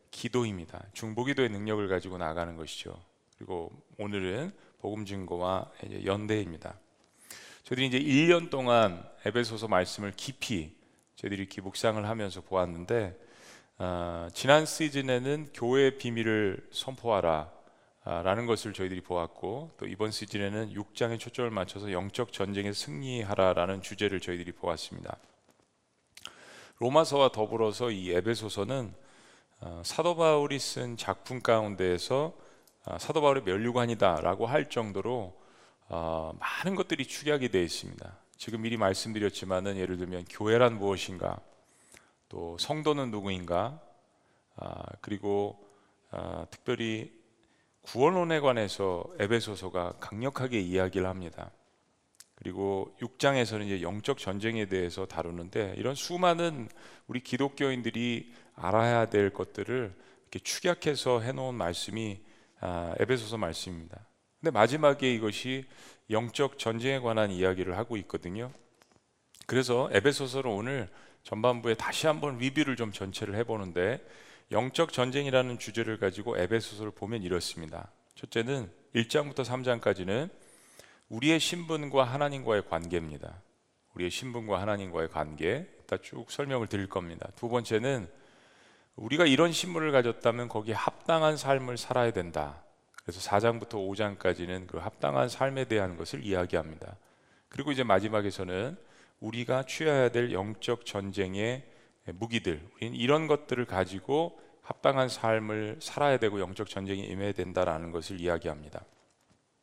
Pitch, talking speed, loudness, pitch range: 110 Hz, 310 characters per minute, -31 LUFS, 95-125 Hz